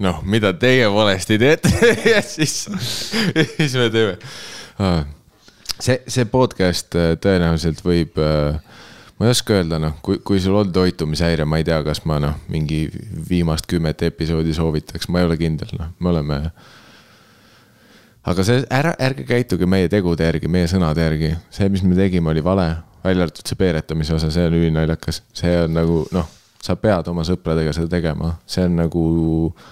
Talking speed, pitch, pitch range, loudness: 165 wpm, 85 Hz, 80-100 Hz, -18 LUFS